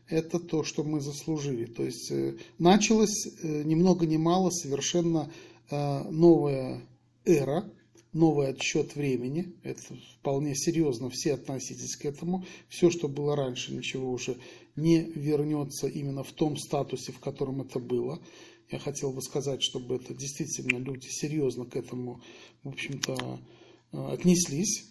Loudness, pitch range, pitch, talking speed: -29 LUFS, 130-165 Hz, 145 Hz, 130 wpm